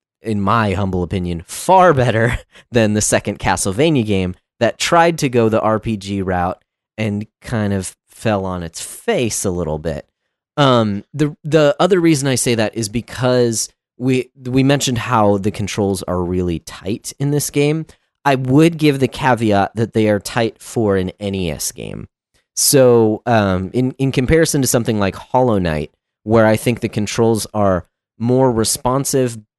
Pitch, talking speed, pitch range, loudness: 115 Hz, 165 wpm, 100-130 Hz, -16 LUFS